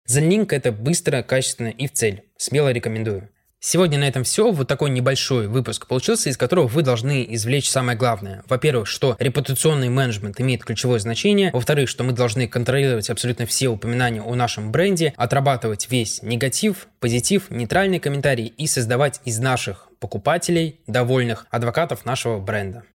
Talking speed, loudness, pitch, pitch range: 150 wpm, -20 LUFS, 125 Hz, 120-145 Hz